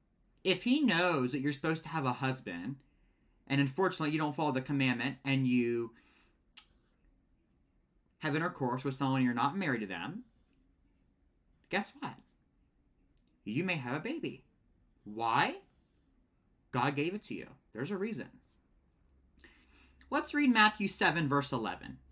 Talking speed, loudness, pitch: 135 wpm, -33 LUFS, 135 Hz